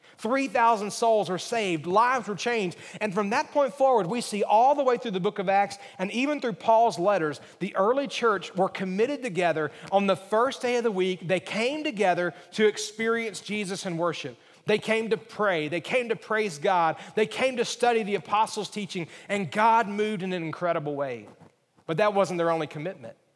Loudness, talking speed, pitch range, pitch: -26 LUFS, 200 wpm, 180-230 Hz, 210 Hz